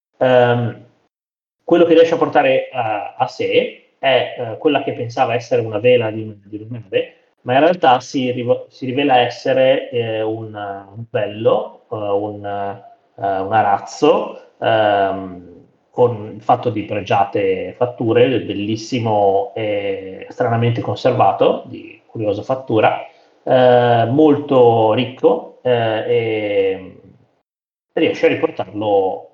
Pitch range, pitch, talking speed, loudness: 105-155 Hz, 120 Hz, 120 wpm, -17 LUFS